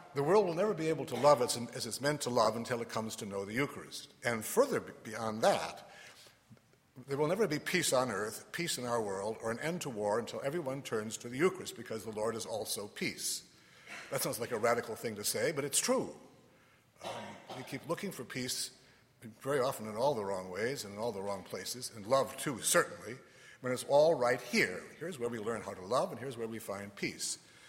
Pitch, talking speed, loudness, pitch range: 125 Hz, 230 wpm, -35 LUFS, 115-140 Hz